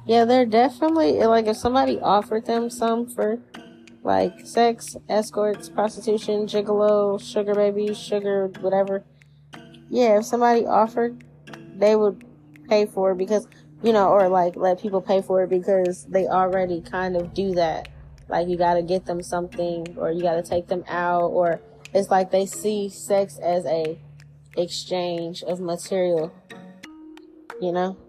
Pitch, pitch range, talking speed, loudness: 190 Hz, 175-210 Hz, 155 wpm, -22 LUFS